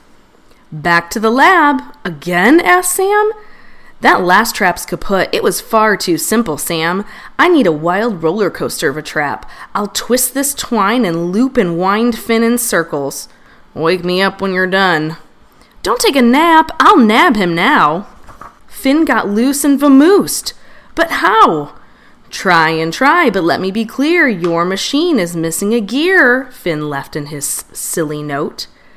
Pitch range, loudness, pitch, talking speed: 170-275 Hz, -12 LUFS, 215 Hz, 160 wpm